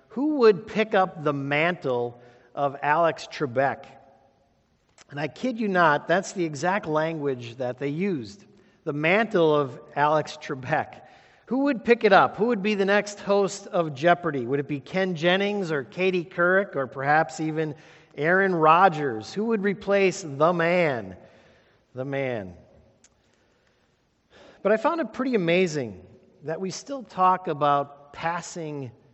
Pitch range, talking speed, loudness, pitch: 145-195 Hz, 145 wpm, -24 LUFS, 170 Hz